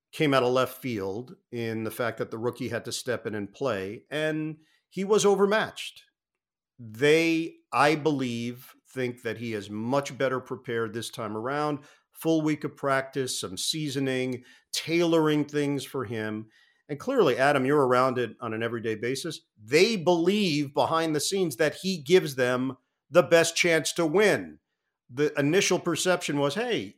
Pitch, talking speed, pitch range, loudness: 140 Hz, 160 wpm, 120-160 Hz, -26 LUFS